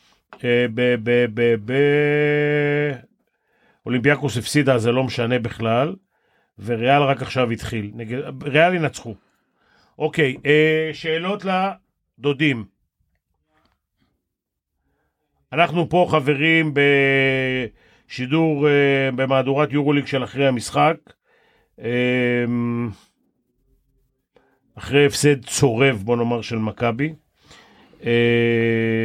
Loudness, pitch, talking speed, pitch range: -19 LUFS, 130 Hz, 80 wpm, 120-150 Hz